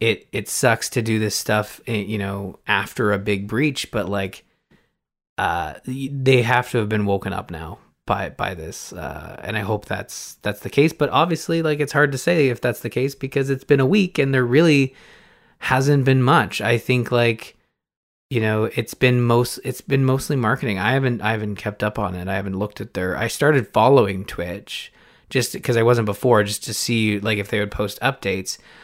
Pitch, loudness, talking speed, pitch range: 120 Hz, -20 LUFS, 210 wpm, 105-135 Hz